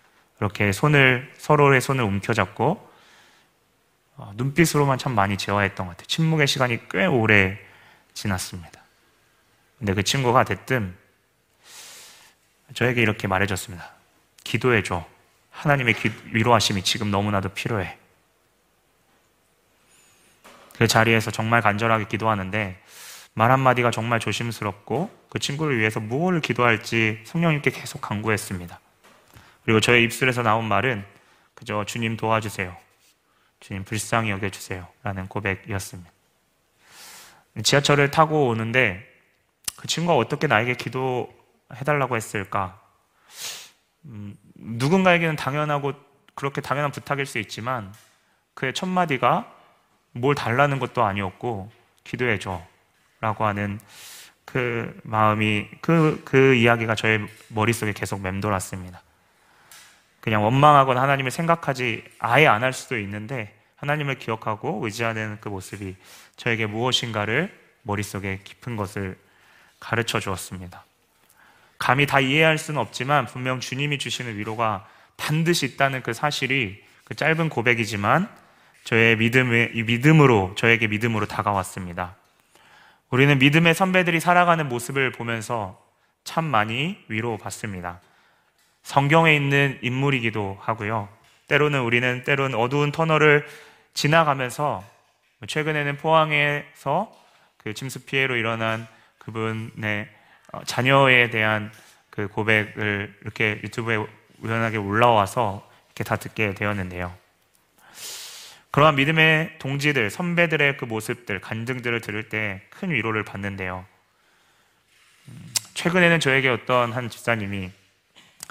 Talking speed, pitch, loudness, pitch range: 290 characters per minute, 115 Hz, -22 LUFS, 105-140 Hz